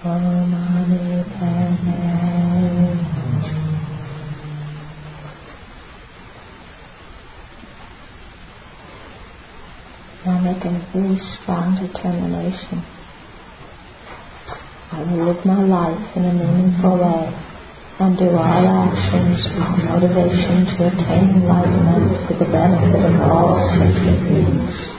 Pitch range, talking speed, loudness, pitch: 155-180 Hz, 75 wpm, -17 LUFS, 175 Hz